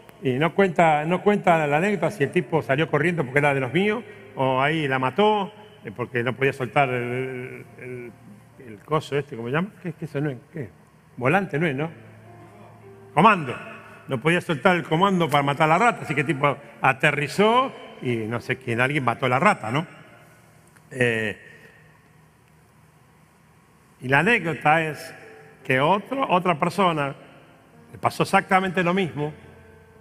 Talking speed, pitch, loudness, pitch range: 170 wpm, 150 Hz, -22 LUFS, 130-175 Hz